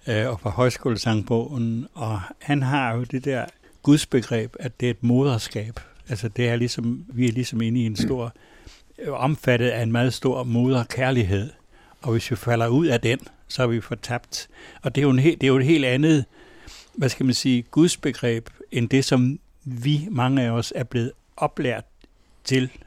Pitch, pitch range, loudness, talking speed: 125 Hz, 115-130 Hz, -23 LUFS, 185 wpm